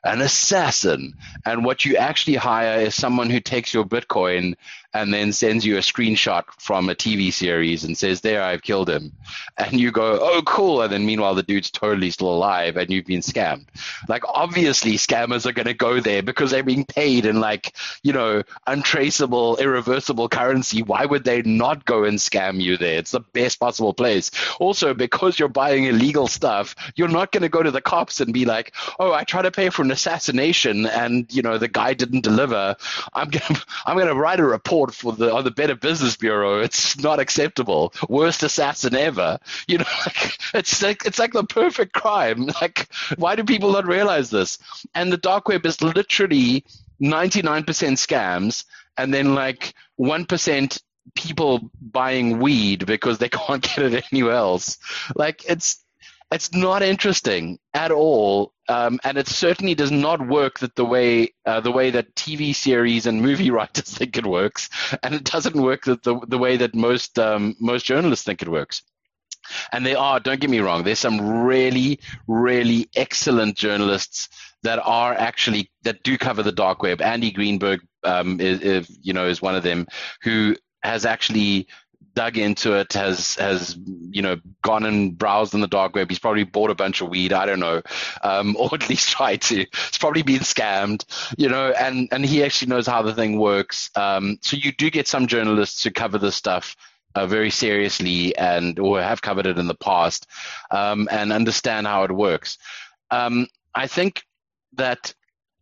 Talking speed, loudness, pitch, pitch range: 190 wpm, -20 LUFS, 120 Hz, 105-140 Hz